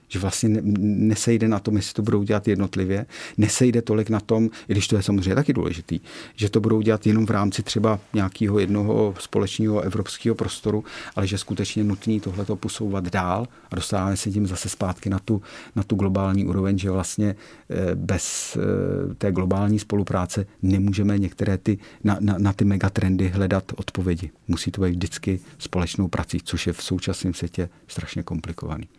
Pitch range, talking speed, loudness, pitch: 95-110 Hz, 170 wpm, -23 LUFS, 100 Hz